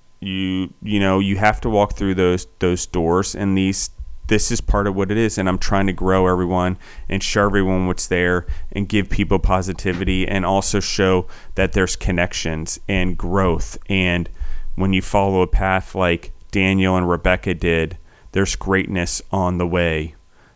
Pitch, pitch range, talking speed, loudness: 95 Hz, 90-95 Hz, 170 wpm, -19 LUFS